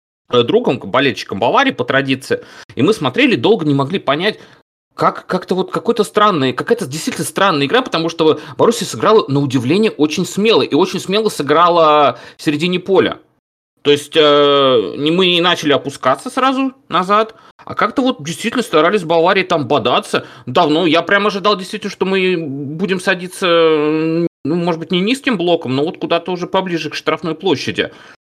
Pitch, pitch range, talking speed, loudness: 170 Hz, 150-200 Hz, 165 wpm, -15 LUFS